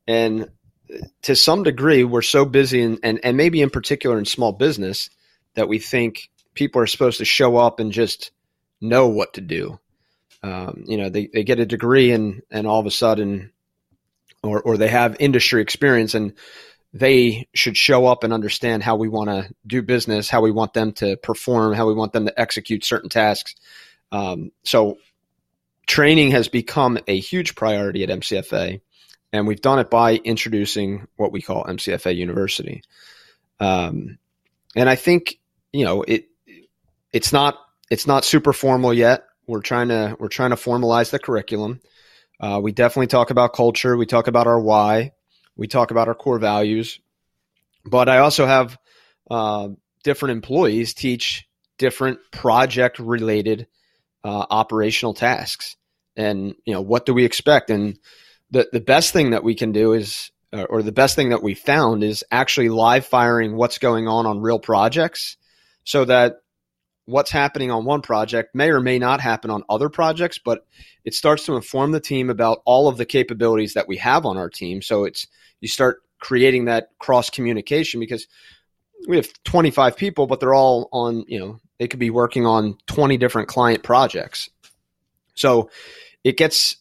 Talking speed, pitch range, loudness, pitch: 175 wpm, 110-130 Hz, -18 LUFS, 115 Hz